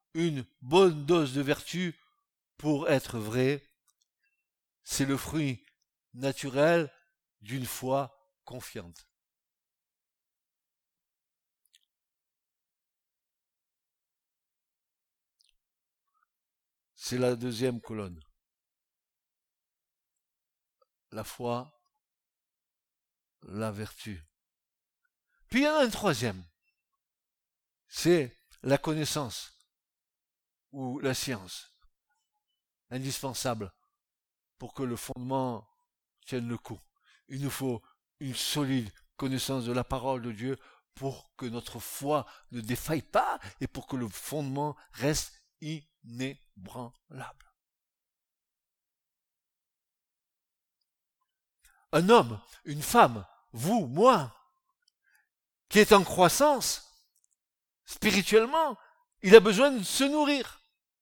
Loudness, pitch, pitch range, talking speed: -28 LUFS, 140 Hz, 125-185 Hz, 85 wpm